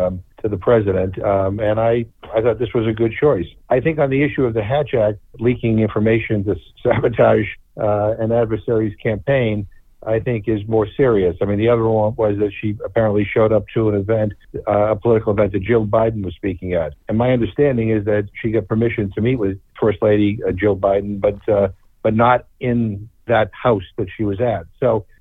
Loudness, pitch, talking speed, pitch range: -18 LUFS, 110 Hz, 210 wpm, 105-115 Hz